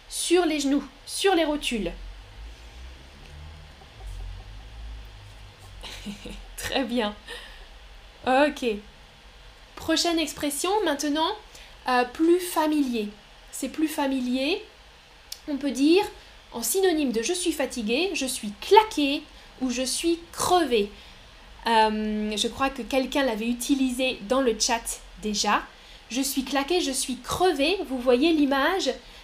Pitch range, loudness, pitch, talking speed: 220-315 Hz, -25 LUFS, 265 Hz, 110 wpm